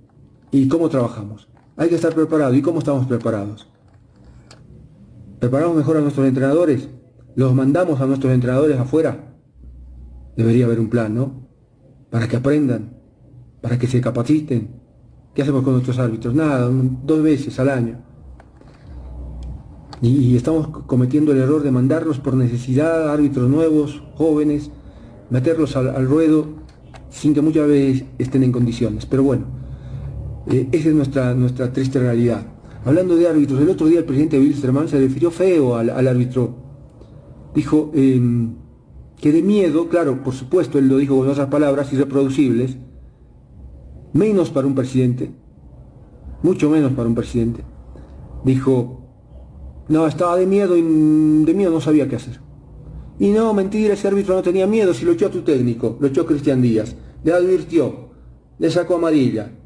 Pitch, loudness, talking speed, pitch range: 135 Hz, -17 LUFS, 150 wpm, 120-155 Hz